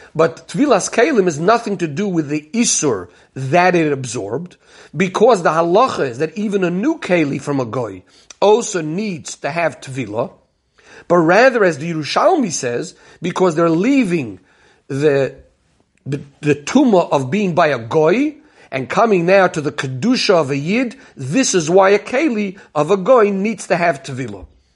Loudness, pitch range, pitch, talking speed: -16 LUFS, 145-205 Hz, 175 Hz, 165 wpm